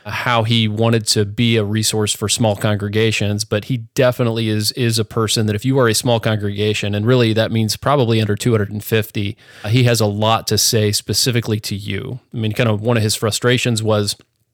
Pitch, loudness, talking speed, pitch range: 110 Hz, -17 LUFS, 200 wpm, 105-120 Hz